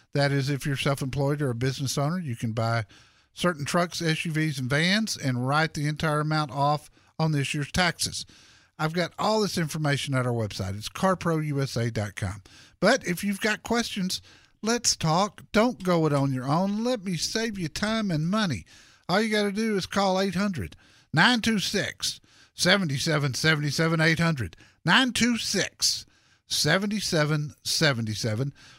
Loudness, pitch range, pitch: -26 LUFS, 135-190 Hz, 155 Hz